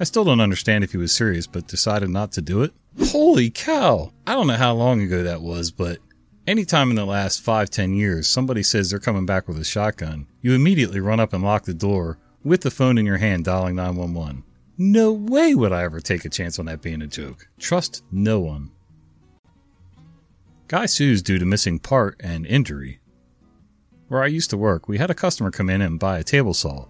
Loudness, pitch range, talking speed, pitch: -20 LUFS, 85-125 Hz, 215 wpm, 100 Hz